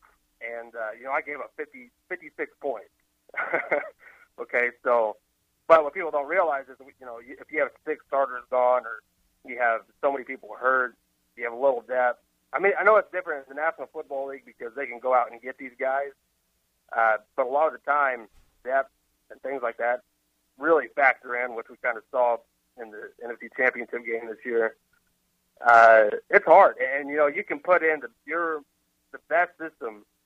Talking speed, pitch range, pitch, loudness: 200 wpm, 115-150 Hz, 130 Hz, -24 LUFS